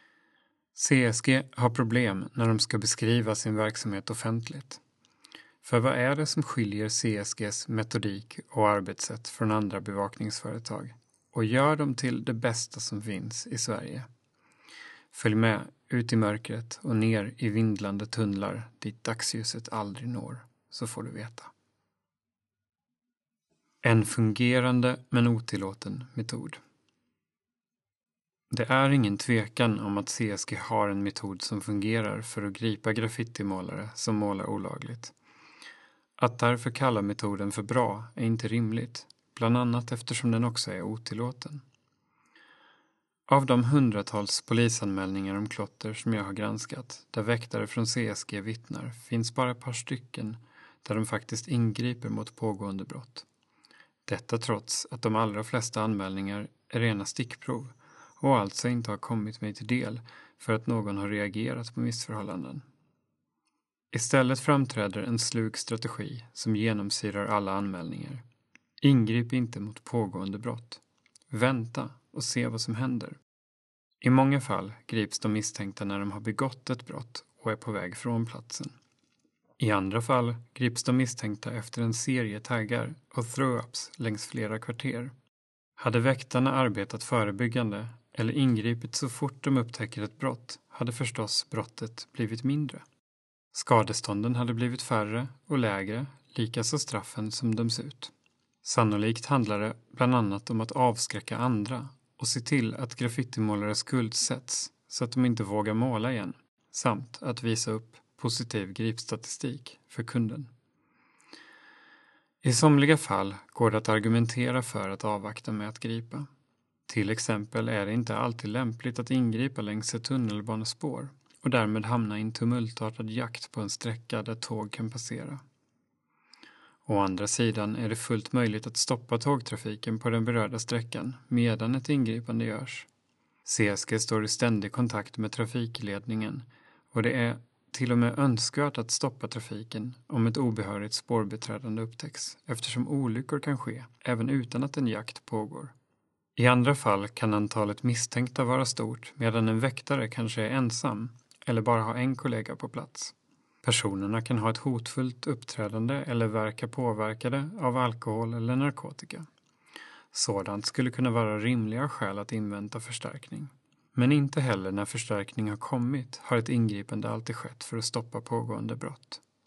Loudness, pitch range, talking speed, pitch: -30 LUFS, 110-125 Hz, 145 wpm, 115 Hz